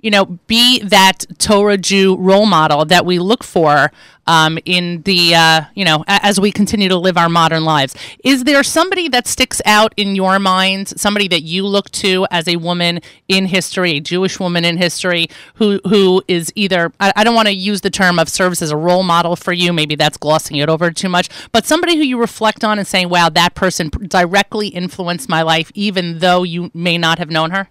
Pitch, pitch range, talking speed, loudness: 185 Hz, 170-205 Hz, 215 wpm, -13 LUFS